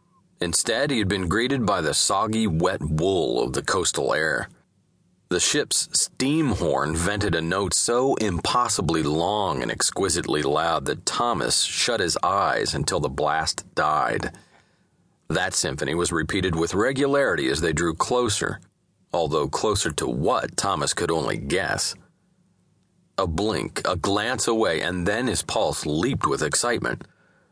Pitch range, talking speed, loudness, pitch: 80-125 Hz, 145 wpm, -23 LUFS, 95 Hz